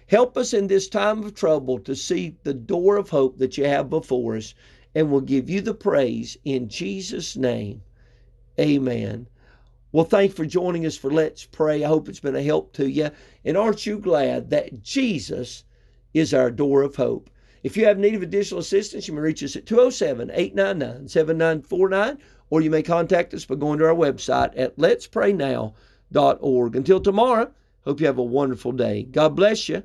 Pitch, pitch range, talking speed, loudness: 155 Hz, 125-195 Hz, 185 wpm, -22 LUFS